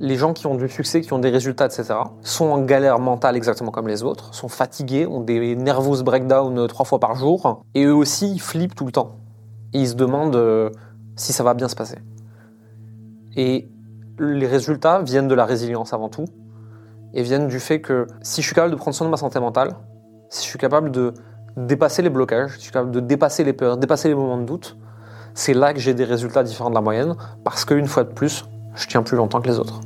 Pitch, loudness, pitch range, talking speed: 125 Hz, -20 LUFS, 110-140 Hz, 230 wpm